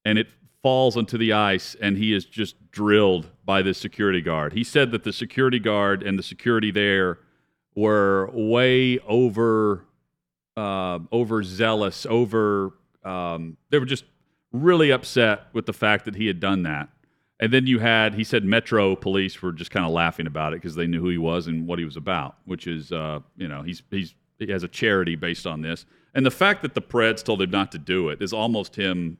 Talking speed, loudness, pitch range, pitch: 210 wpm, -23 LUFS, 90-115 Hz, 105 Hz